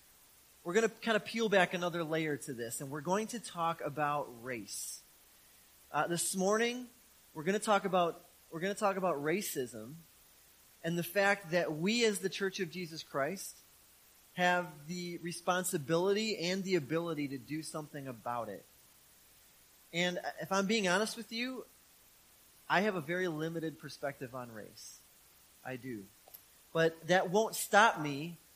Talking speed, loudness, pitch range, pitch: 160 wpm, -34 LUFS, 150-195 Hz, 170 Hz